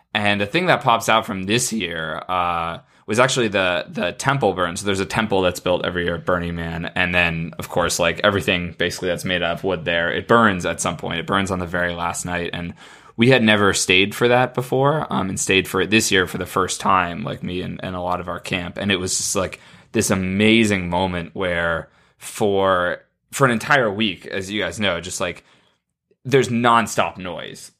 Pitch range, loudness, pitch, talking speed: 85-110 Hz, -19 LUFS, 95 Hz, 220 wpm